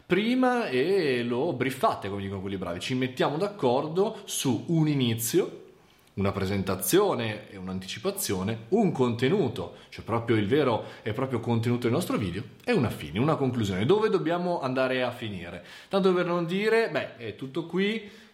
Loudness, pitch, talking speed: -27 LUFS, 130 Hz, 155 wpm